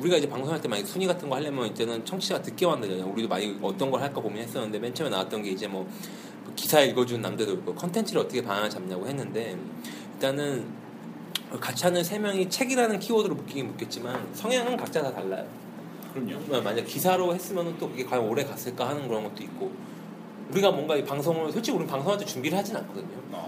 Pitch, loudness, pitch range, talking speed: 175 Hz, -29 LUFS, 125-200 Hz, 445 characters per minute